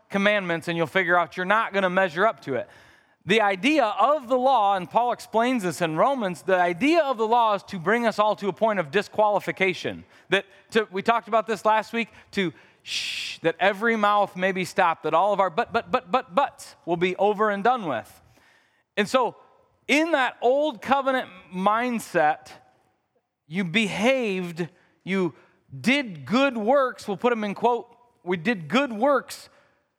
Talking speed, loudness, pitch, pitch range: 185 wpm, -24 LUFS, 210 Hz, 185-245 Hz